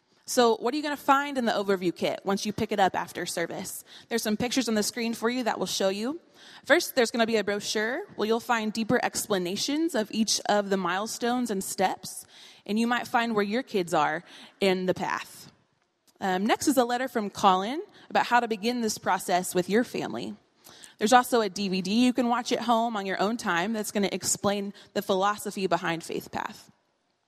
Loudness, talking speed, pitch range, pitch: -27 LUFS, 215 wpm, 195-240 Hz, 220 Hz